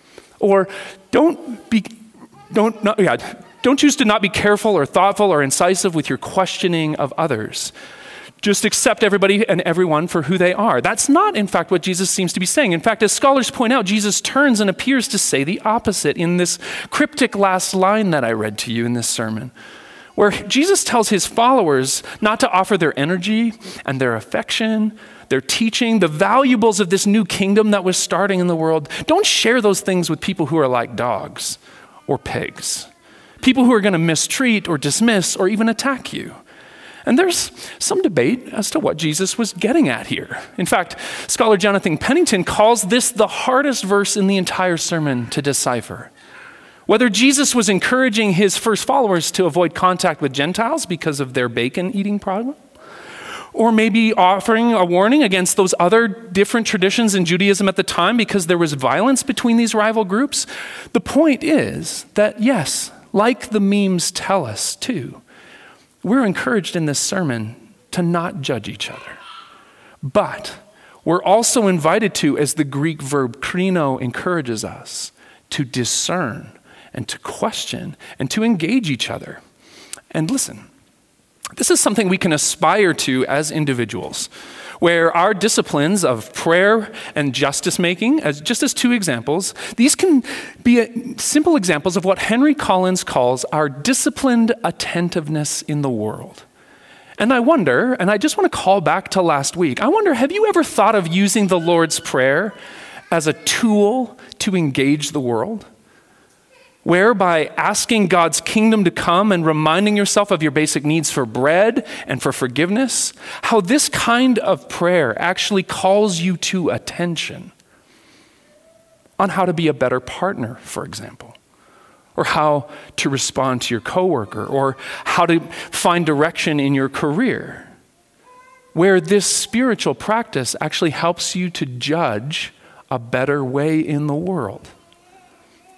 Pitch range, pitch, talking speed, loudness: 160-230 Hz, 195 Hz, 160 wpm, -17 LUFS